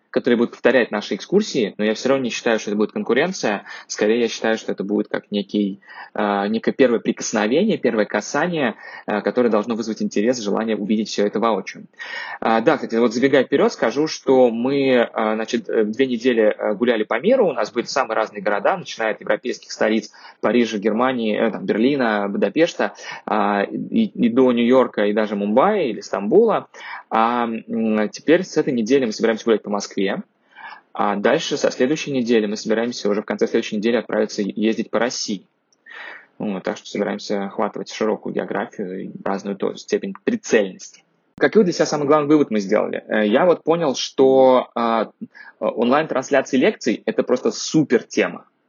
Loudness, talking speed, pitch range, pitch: -20 LUFS, 165 wpm, 105-130 Hz, 115 Hz